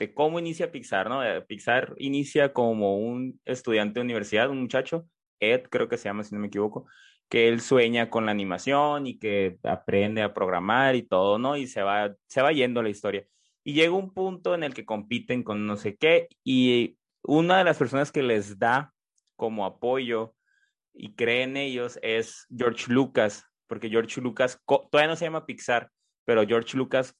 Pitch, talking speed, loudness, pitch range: 125 Hz, 185 wpm, -26 LUFS, 110-145 Hz